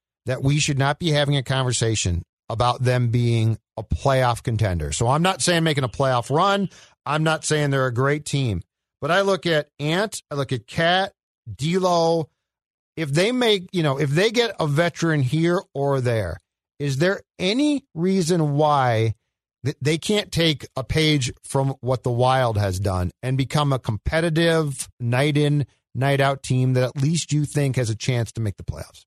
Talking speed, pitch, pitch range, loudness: 185 wpm, 140 Hz, 125-160 Hz, -22 LUFS